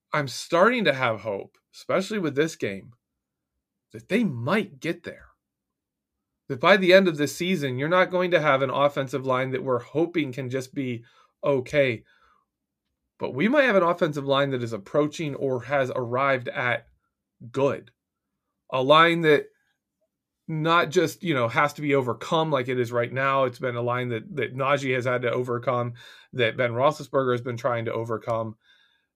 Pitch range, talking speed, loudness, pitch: 125-160 Hz, 175 wpm, -24 LUFS, 140 Hz